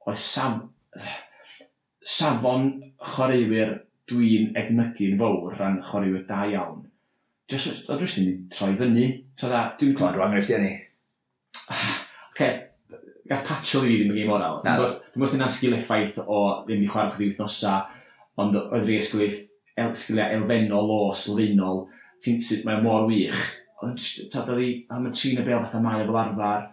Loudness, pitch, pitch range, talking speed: -25 LUFS, 110 Hz, 105-120 Hz, 150 wpm